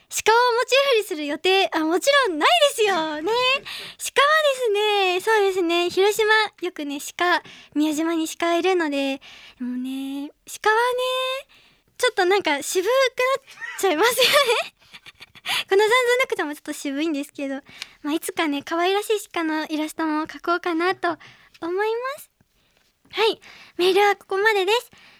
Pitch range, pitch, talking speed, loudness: 310-440 Hz, 365 Hz, 310 characters per minute, -21 LUFS